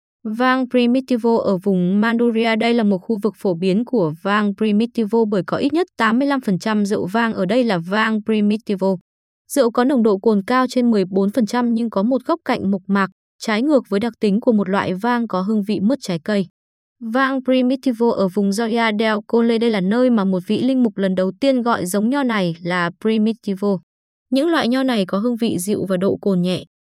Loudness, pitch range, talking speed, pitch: -18 LUFS, 195-245 Hz, 210 wpm, 220 Hz